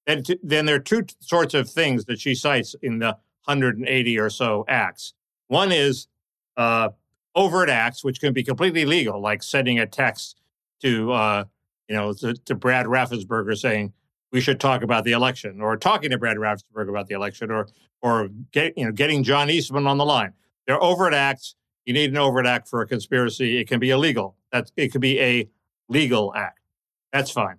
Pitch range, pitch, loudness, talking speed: 110-140 Hz, 125 Hz, -22 LUFS, 190 wpm